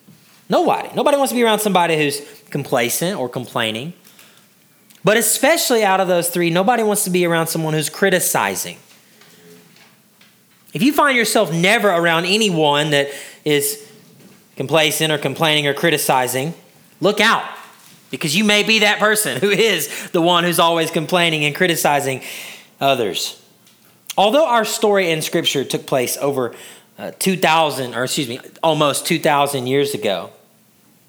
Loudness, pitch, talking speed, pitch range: -16 LUFS, 170 Hz, 145 wpm, 145-205 Hz